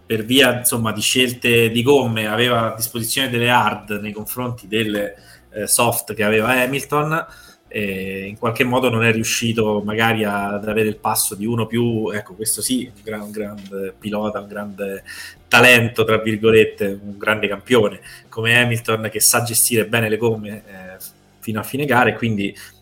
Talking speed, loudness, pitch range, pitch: 170 wpm, -18 LUFS, 105-120 Hz, 110 Hz